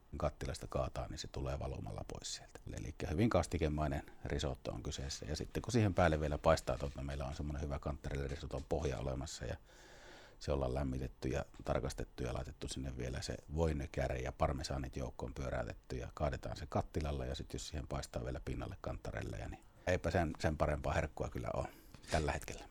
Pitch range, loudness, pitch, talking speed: 65-80 Hz, -40 LUFS, 70 Hz, 180 wpm